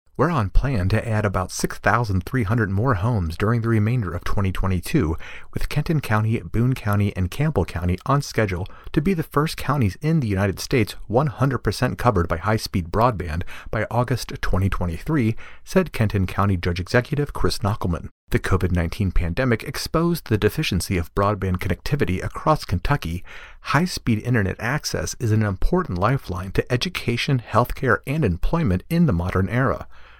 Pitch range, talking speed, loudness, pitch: 95-125 Hz, 150 wpm, -22 LUFS, 105 Hz